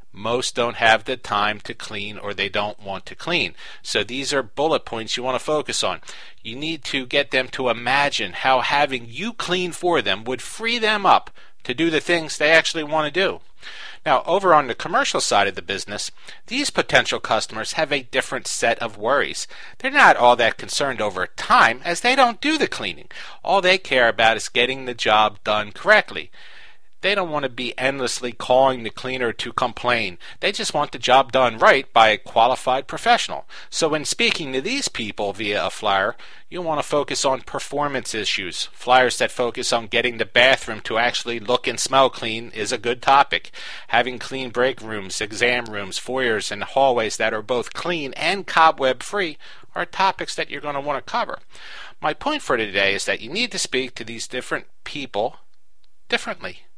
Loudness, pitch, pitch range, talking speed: -20 LUFS, 130 Hz, 115-160 Hz, 195 wpm